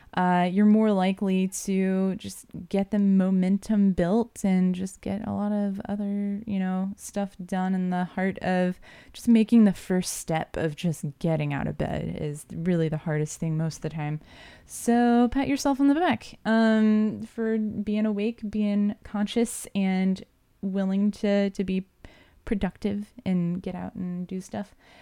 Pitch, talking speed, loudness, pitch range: 195 Hz, 165 wpm, -26 LUFS, 180-210 Hz